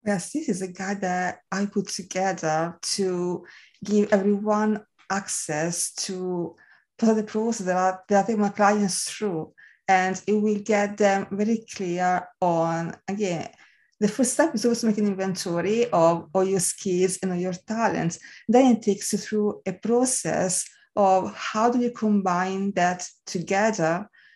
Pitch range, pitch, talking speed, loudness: 180-210 Hz, 195 Hz, 160 wpm, -24 LUFS